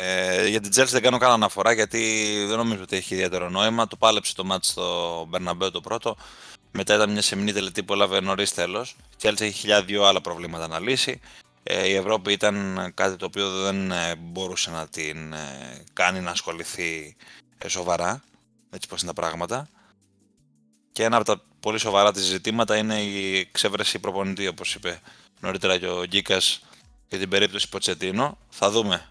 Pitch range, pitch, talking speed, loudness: 90-105 Hz, 100 Hz, 175 wpm, -23 LUFS